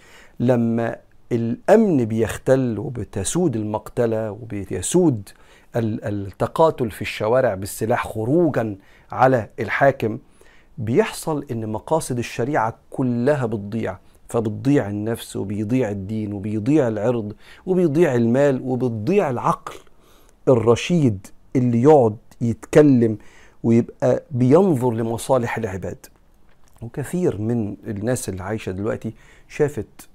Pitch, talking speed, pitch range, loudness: 115 Hz, 90 wpm, 105-130 Hz, -21 LUFS